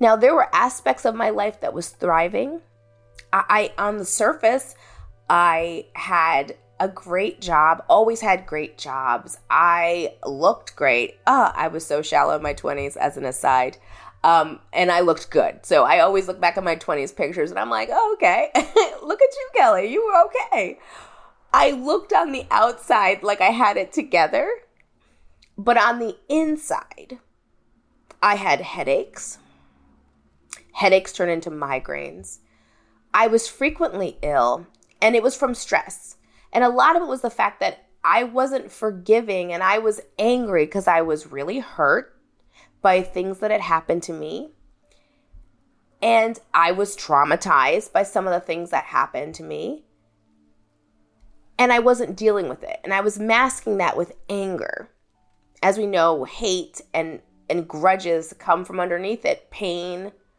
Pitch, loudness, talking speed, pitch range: 185 Hz, -20 LUFS, 160 wpm, 155-230 Hz